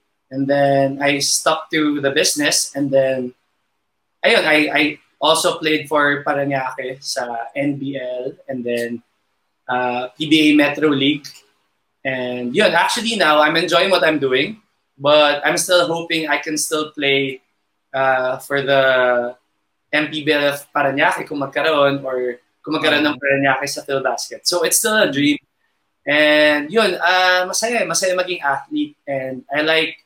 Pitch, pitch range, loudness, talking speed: 140 Hz, 130-155 Hz, -17 LUFS, 135 wpm